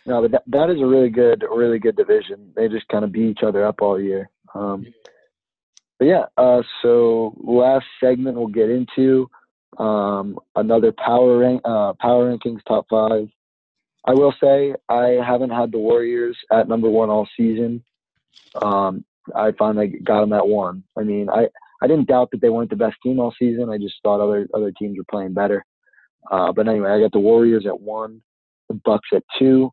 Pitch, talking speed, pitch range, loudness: 115 Hz, 195 wpm, 105-125 Hz, -18 LUFS